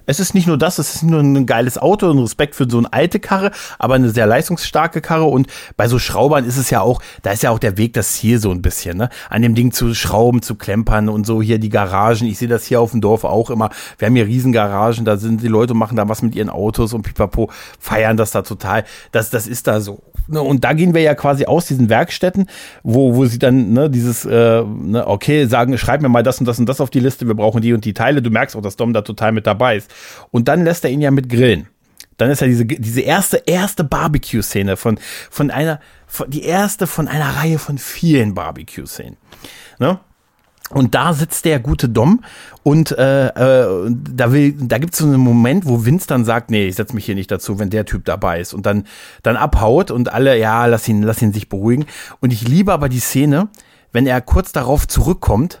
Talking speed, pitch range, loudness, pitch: 235 wpm, 110-145 Hz, -15 LUFS, 120 Hz